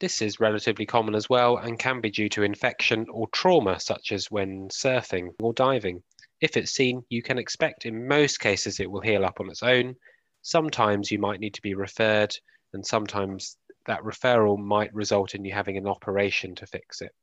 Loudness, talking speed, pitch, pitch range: -25 LUFS, 200 wpm, 105 Hz, 100-120 Hz